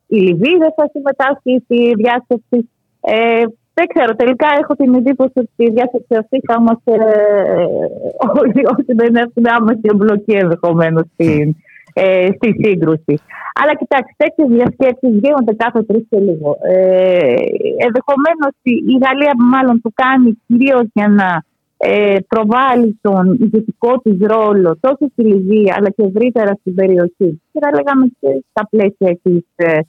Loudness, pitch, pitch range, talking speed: -12 LUFS, 230 Hz, 200-265 Hz, 145 wpm